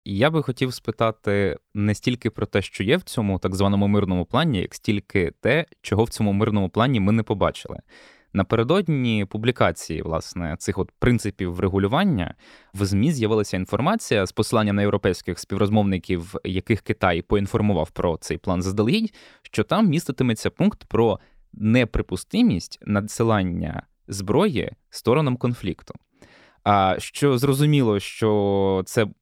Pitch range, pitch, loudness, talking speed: 95-120 Hz, 105 Hz, -22 LUFS, 135 wpm